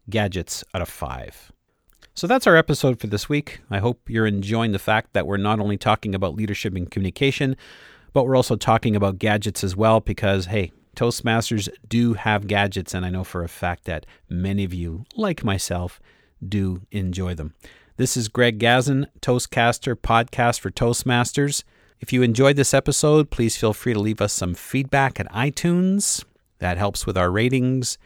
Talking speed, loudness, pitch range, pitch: 175 wpm, -21 LUFS, 95-125 Hz, 110 Hz